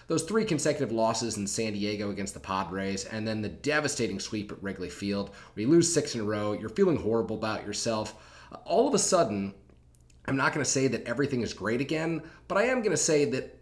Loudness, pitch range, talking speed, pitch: -29 LUFS, 100-145 Hz, 225 wpm, 110 Hz